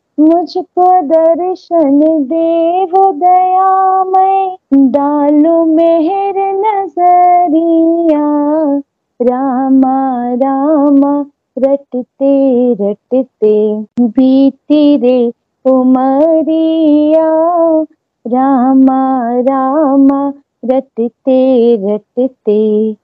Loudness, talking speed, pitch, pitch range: -10 LUFS, 45 wpm, 285 Hz, 260-330 Hz